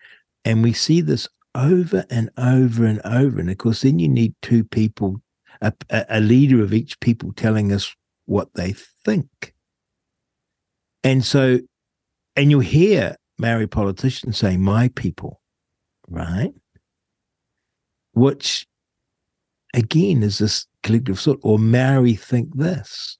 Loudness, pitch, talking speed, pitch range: -19 LUFS, 115 Hz, 130 wpm, 110-135 Hz